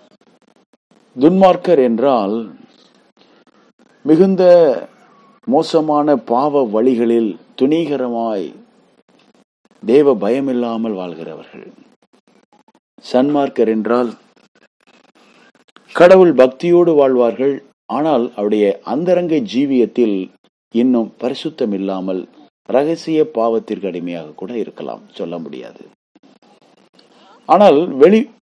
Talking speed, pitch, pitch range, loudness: 60 wpm, 130 Hz, 115-165 Hz, -14 LUFS